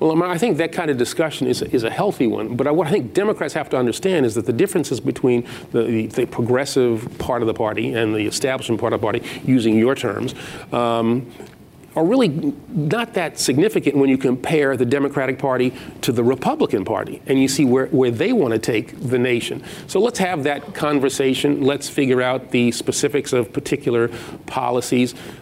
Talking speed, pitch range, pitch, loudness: 195 wpm, 120-145 Hz, 130 Hz, -19 LUFS